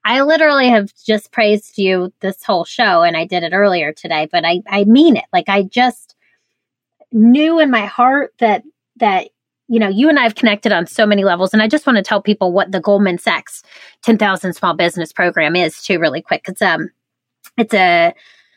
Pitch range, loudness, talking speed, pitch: 190-250 Hz, -14 LUFS, 205 wpm, 215 Hz